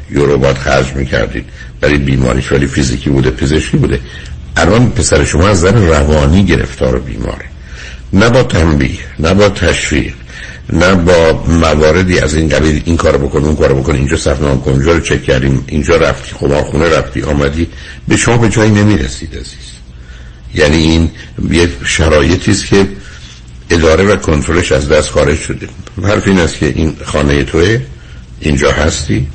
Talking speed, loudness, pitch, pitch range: 155 wpm, -11 LUFS, 70 Hz, 65-85 Hz